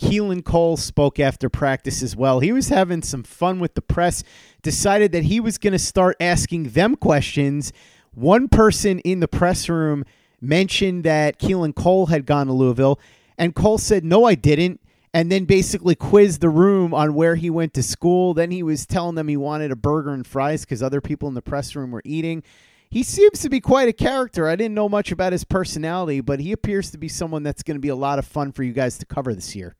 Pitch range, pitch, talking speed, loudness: 140-185 Hz, 160 Hz, 225 wpm, -19 LUFS